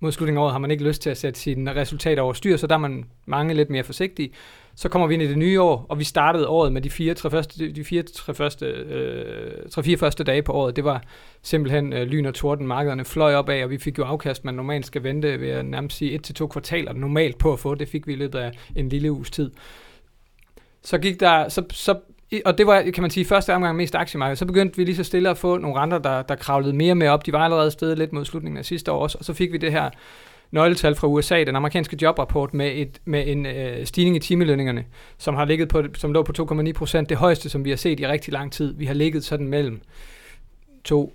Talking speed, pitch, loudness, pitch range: 265 wpm, 150 Hz, -22 LUFS, 140-165 Hz